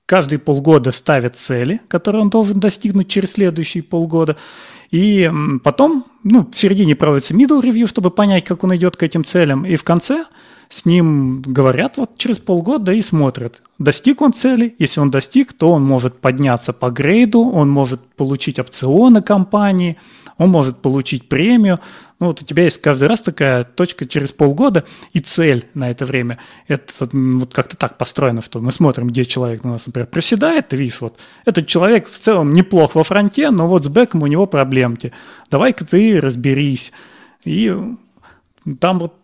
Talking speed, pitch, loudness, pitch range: 170 wpm, 165 Hz, -14 LUFS, 135-205 Hz